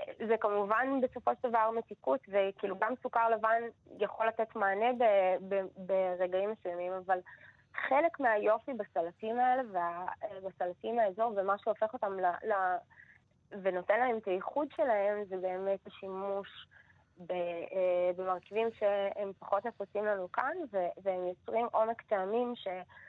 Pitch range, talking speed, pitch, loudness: 185-230 Hz, 125 wpm, 205 Hz, -33 LUFS